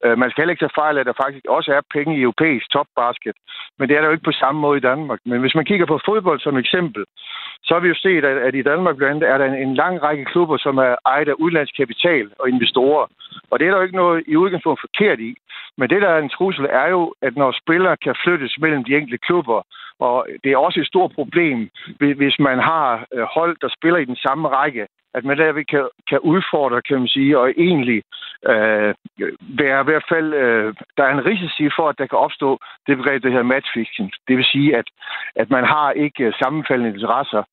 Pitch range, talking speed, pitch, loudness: 130-165 Hz, 225 wpm, 145 Hz, -17 LUFS